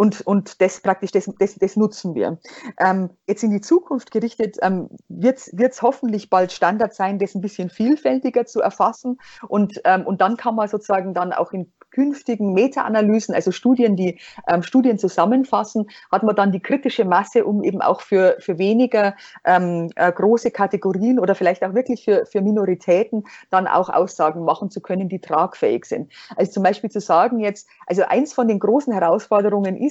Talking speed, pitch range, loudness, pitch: 185 wpm, 185-230 Hz, -19 LUFS, 205 Hz